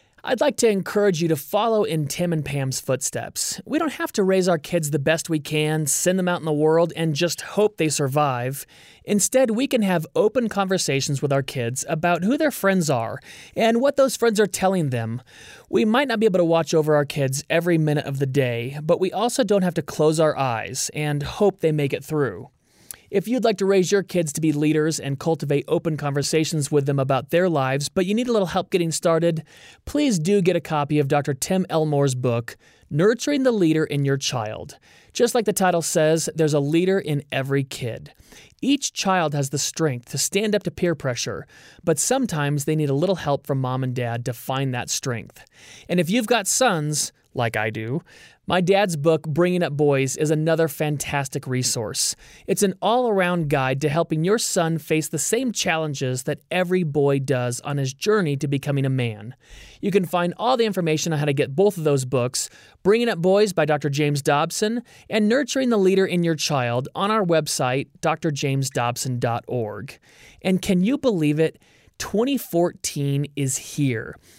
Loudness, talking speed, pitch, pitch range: -22 LUFS, 200 wpm, 160 Hz, 140-190 Hz